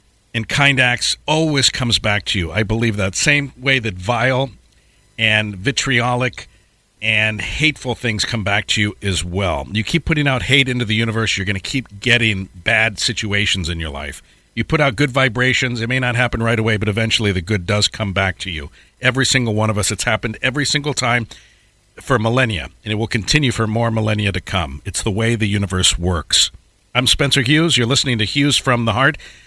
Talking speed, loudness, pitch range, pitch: 205 wpm, -17 LUFS, 100-125 Hz, 115 Hz